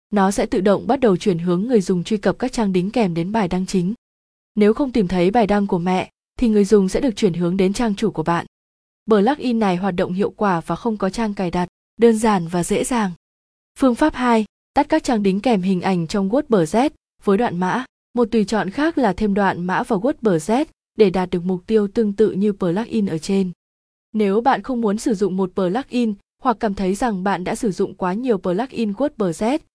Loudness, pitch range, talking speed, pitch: -19 LUFS, 185-235 Hz, 240 wpm, 210 Hz